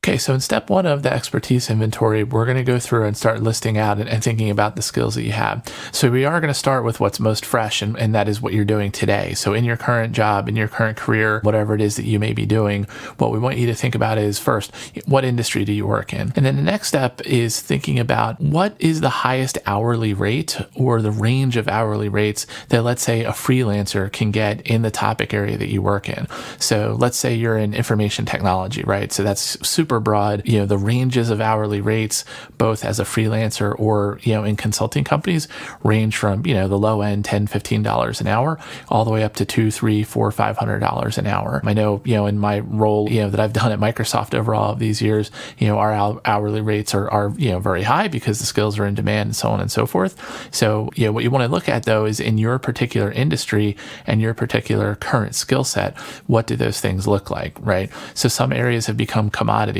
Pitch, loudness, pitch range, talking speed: 110 Hz, -19 LUFS, 105-120 Hz, 240 wpm